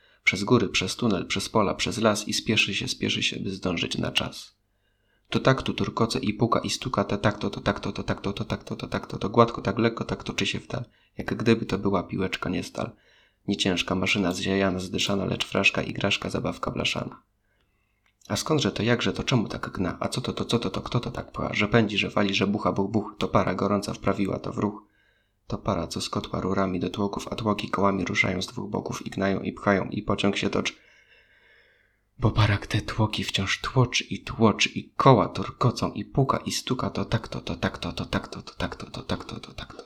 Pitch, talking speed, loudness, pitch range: 100 Hz, 225 wpm, -26 LUFS, 95-115 Hz